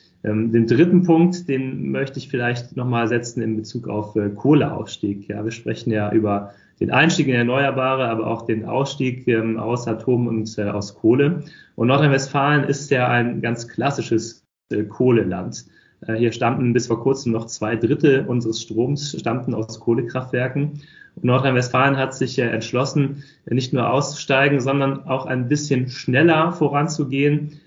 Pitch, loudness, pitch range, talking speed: 125 Hz, -20 LUFS, 115-140 Hz, 160 wpm